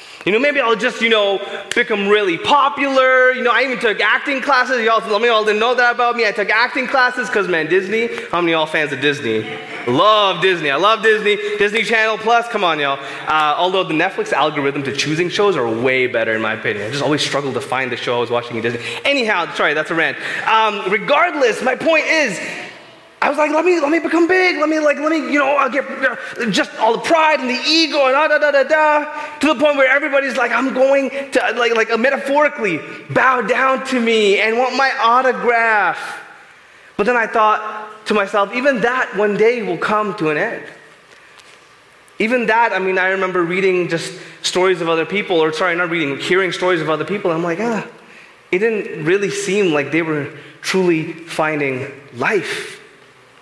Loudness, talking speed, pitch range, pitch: -16 LUFS, 210 wpm, 180-265 Hz, 220 Hz